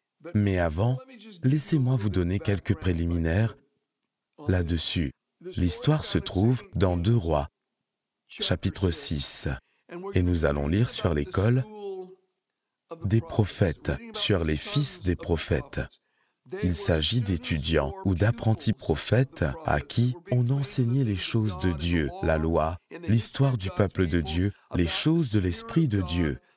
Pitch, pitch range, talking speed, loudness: 100 Hz, 85-125 Hz, 125 wpm, -26 LUFS